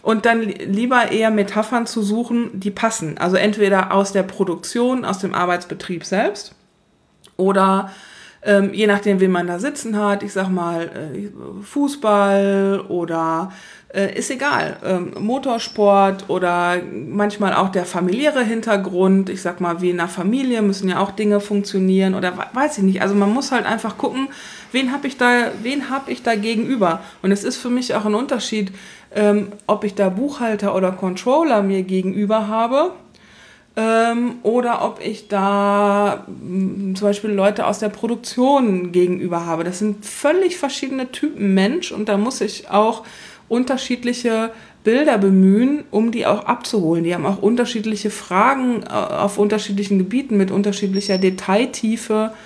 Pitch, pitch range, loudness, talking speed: 205 Hz, 195-230 Hz, -19 LUFS, 150 wpm